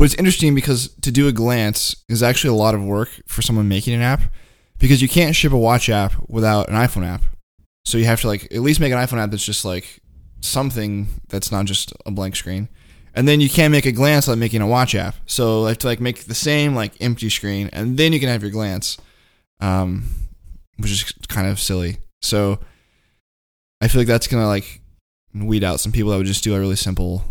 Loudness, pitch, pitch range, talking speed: -18 LUFS, 105 Hz, 95-120 Hz, 230 wpm